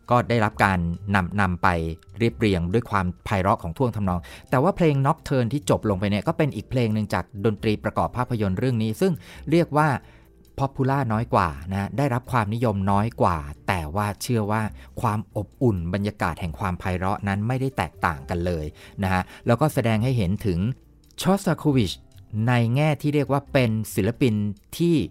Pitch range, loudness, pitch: 95-130 Hz, -24 LUFS, 110 Hz